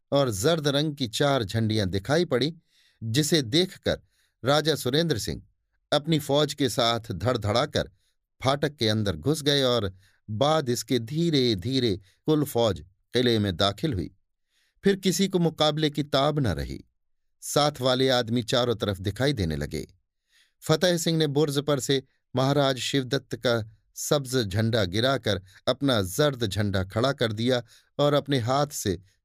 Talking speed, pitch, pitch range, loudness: 150 wpm, 130 Hz, 110-145 Hz, -25 LUFS